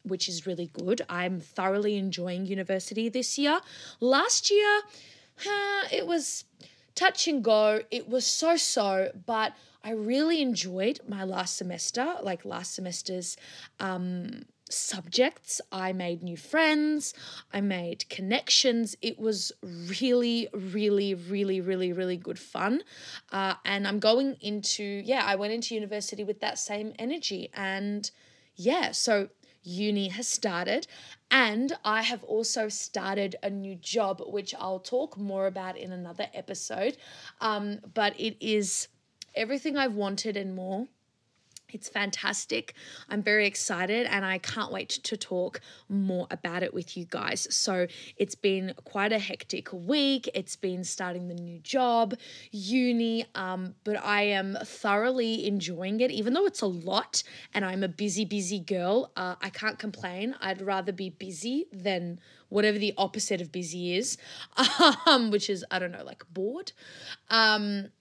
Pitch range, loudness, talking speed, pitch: 190-235 Hz, -29 LUFS, 145 wpm, 205 Hz